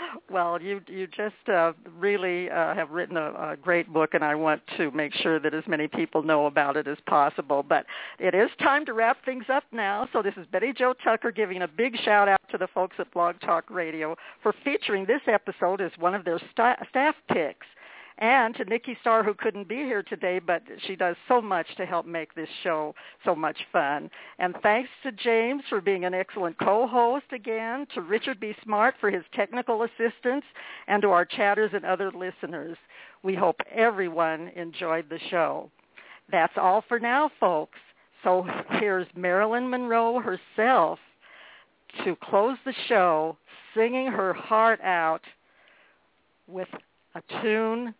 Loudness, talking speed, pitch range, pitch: -26 LUFS, 175 wpm, 175-235 Hz, 200 Hz